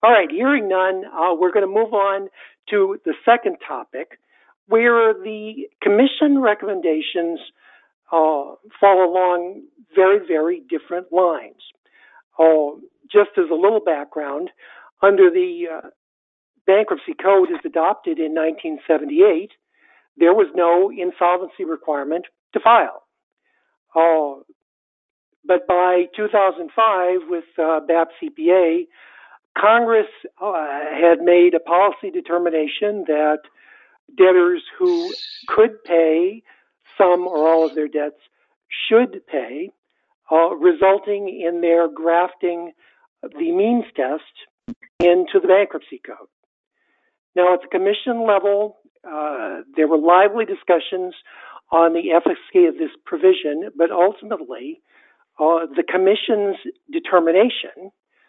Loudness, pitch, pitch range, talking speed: -18 LUFS, 190 Hz, 170-255 Hz, 110 wpm